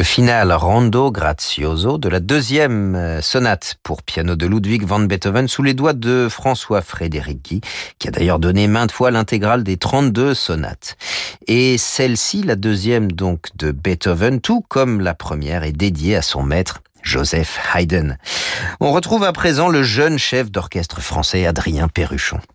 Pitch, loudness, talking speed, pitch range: 100 Hz, -17 LUFS, 160 wpm, 85-125 Hz